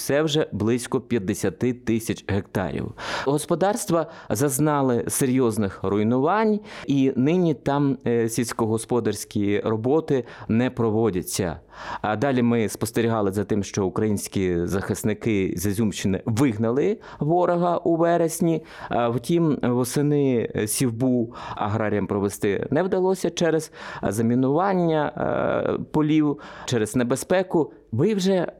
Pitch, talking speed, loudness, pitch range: 125 Hz, 100 wpm, -23 LUFS, 110-155 Hz